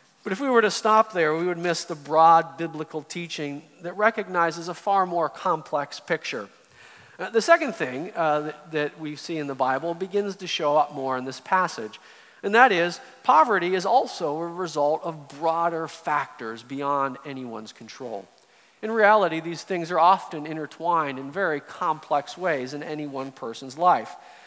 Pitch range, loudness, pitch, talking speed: 145-180 Hz, -24 LUFS, 165 Hz, 175 wpm